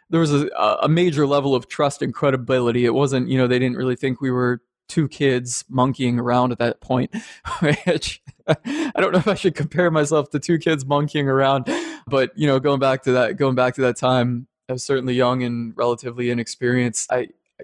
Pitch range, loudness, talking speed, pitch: 125-150 Hz, -20 LUFS, 210 wpm, 135 Hz